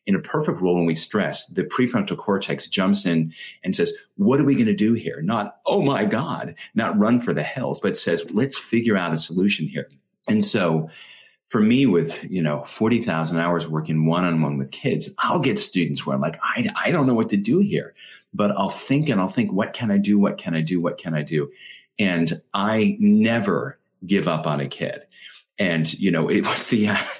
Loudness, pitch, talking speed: -22 LUFS, 95 Hz, 220 wpm